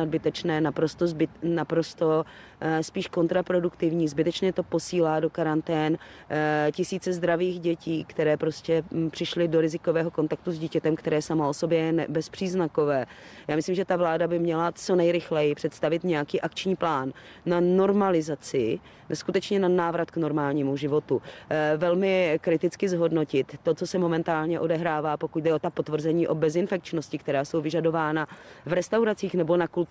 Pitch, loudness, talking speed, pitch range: 165 Hz, -26 LUFS, 145 wpm, 155-175 Hz